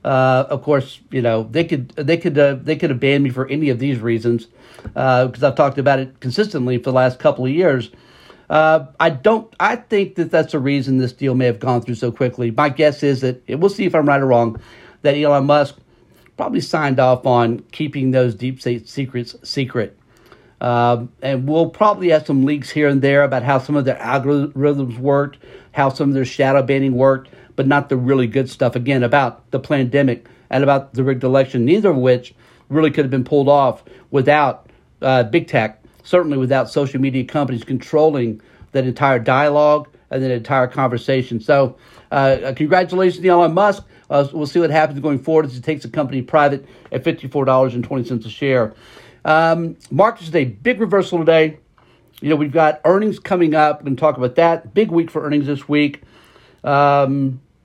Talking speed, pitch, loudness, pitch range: 195 wpm, 140 Hz, -17 LUFS, 130-150 Hz